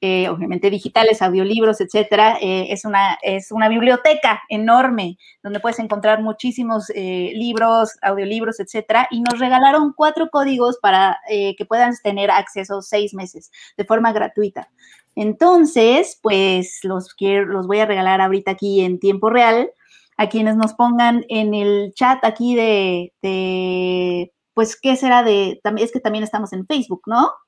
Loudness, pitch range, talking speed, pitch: -17 LUFS, 195-235 Hz, 155 wpm, 215 Hz